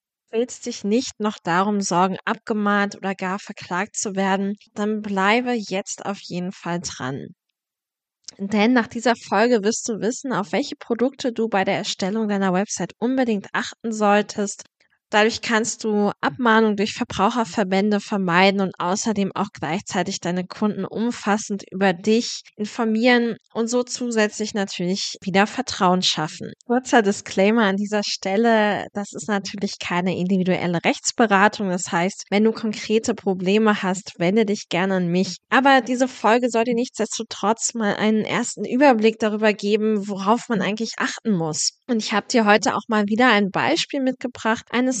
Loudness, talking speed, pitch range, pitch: -21 LUFS, 150 wpm, 195-230 Hz, 210 Hz